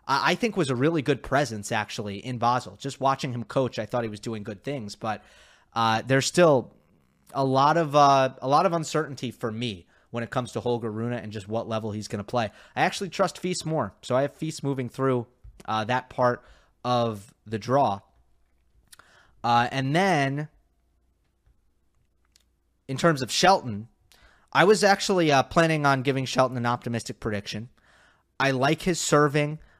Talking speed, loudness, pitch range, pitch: 175 wpm, -25 LUFS, 110-145 Hz, 125 Hz